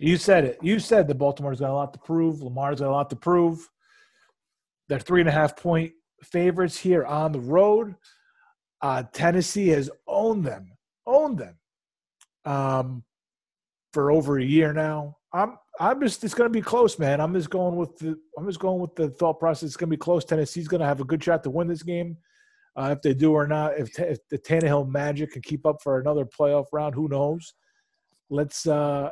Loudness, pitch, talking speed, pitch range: -24 LUFS, 160 Hz, 210 wpm, 145-180 Hz